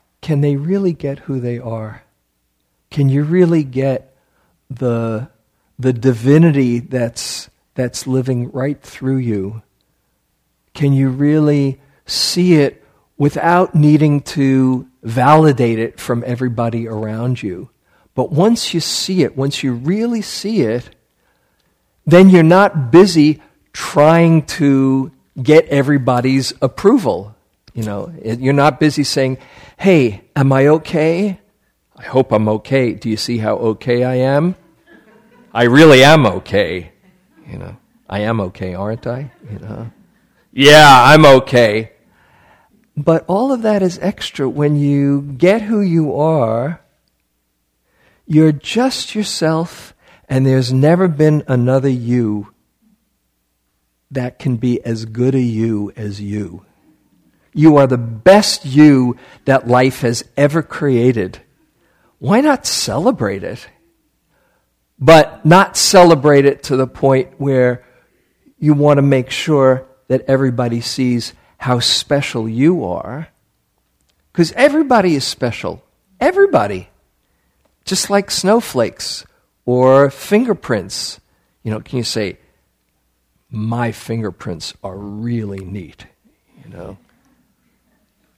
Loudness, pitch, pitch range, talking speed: -14 LUFS, 130 Hz, 115-155 Hz, 120 wpm